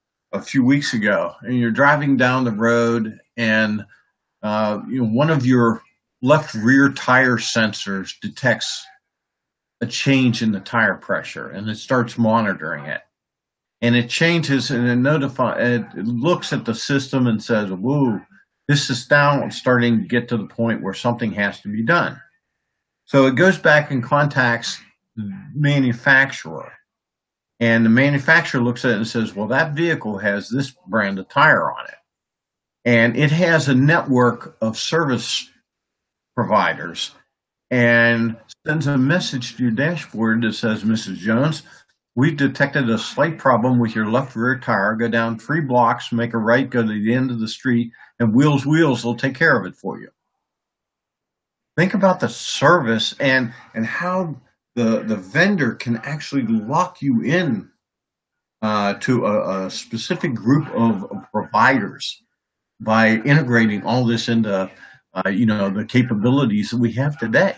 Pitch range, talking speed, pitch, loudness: 115-140 Hz, 160 wpm, 120 Hz, -18 LUFS